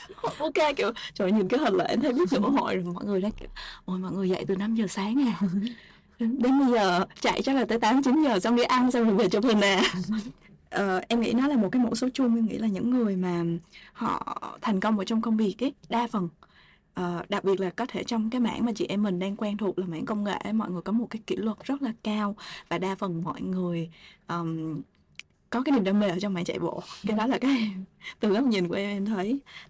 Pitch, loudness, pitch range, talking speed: 210 Hz, -27 LUFS, 185-235 Hz, 265 wpm